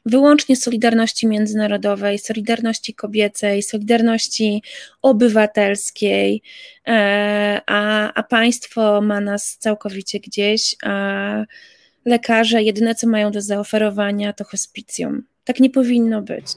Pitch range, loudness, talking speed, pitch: 205-230 Hz, -17 LUFS, 100 wpm, 215 Hz